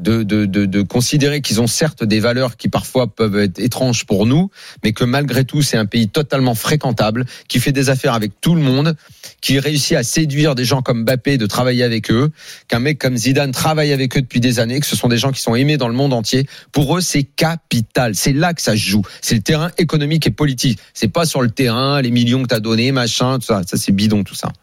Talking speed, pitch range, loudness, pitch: 250 wpm, 115-145 Hz, -16 LUFS, 130 Hz